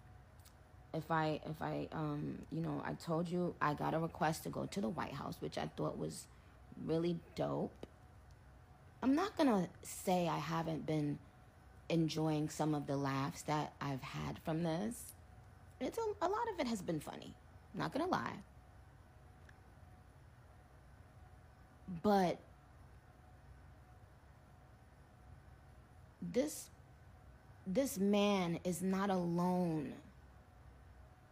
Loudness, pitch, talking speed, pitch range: -39 LUFS, 165 Hz, 125 wpm, 150-190 Hz